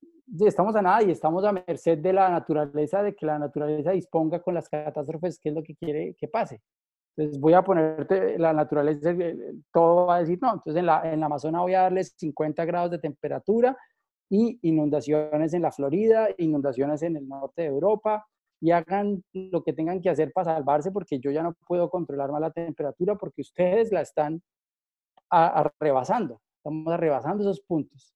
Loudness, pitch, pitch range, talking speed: -25 LUFS, 165 Hz, 150-185 Hz, 185 wpm